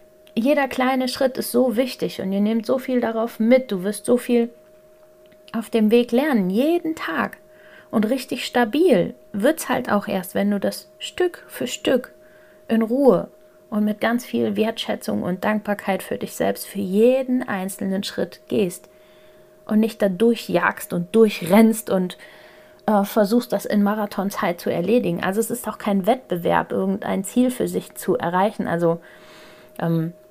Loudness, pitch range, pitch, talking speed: -21 LUFS, 200-255 Hz, 225 Hz, 160 wpm